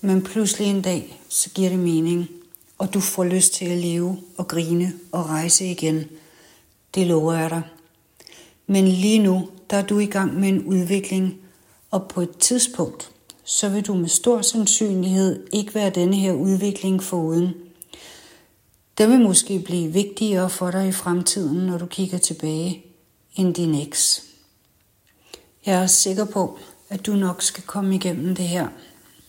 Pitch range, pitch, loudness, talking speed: 175-195 Hz, 185 Hz, -20 LUFS, 160 wpm